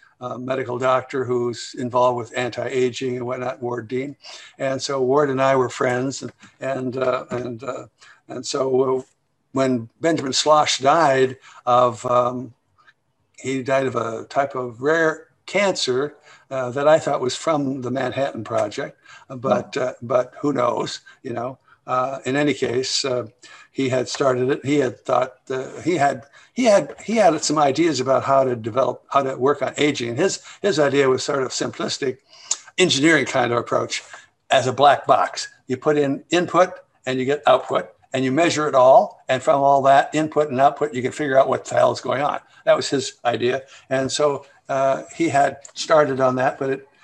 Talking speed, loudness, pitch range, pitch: 180 wpm, -20 LUFS, 125-145 Hz, 135 Hz